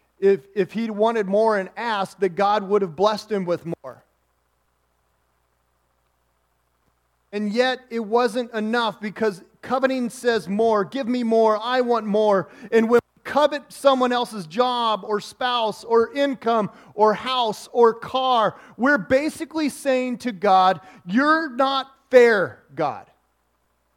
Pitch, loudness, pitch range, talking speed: 220 Hz, -21 LUFS, 190-250 Hz, 135 wpm